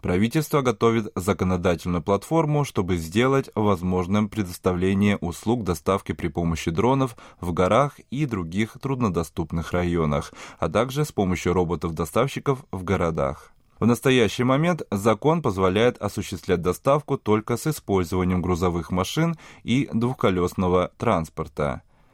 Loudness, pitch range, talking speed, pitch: -24 LUFS, 90-125 Hz, 110 wpm, 100 Hz